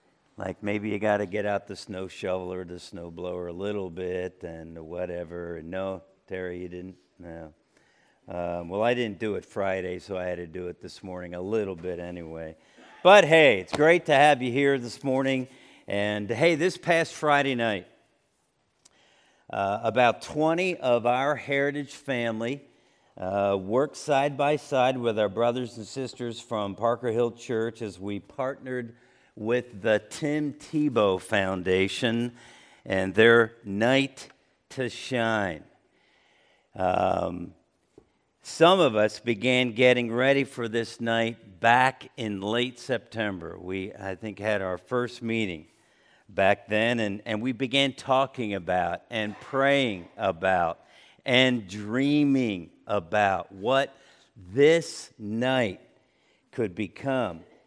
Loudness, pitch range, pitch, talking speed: -26 LUFS, 95-130 Hz, 115 Hz, 140 wpm